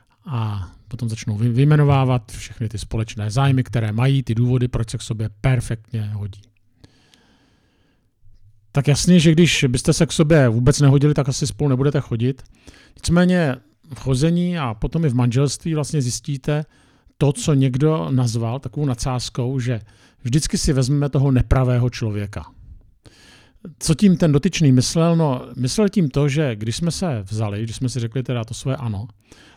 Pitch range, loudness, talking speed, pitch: 115-145 Hz, -19 LUFS, 160 wpm, 130 Hz